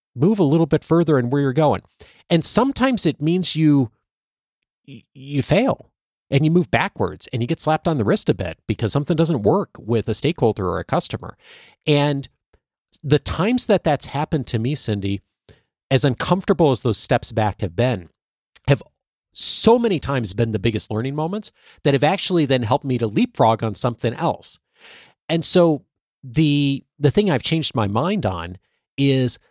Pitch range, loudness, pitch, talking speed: 115-160 Hz, -20 LUFS, 140 Hz, 175 wpm